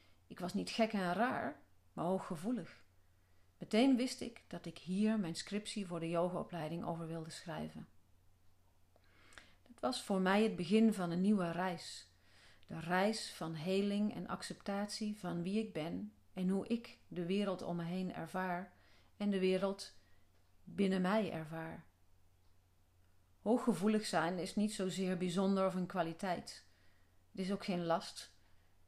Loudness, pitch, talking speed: -38 LUFS, 175 Hz, 150 wpm